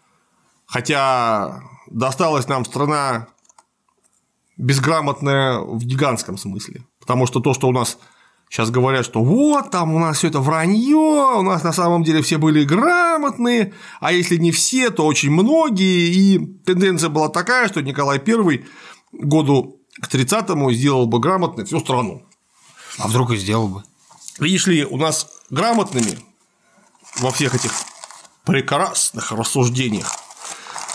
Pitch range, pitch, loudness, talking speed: 125-180 Hz, 150 Hz, -17 LUFS, 130 wpm